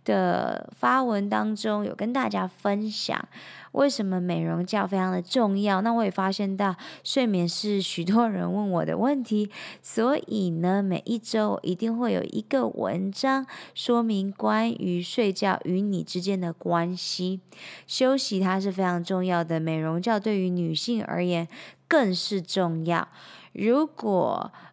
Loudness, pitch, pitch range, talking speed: -26 LUFS, 195 Hz, 180-225 Hz, 220 characters per minute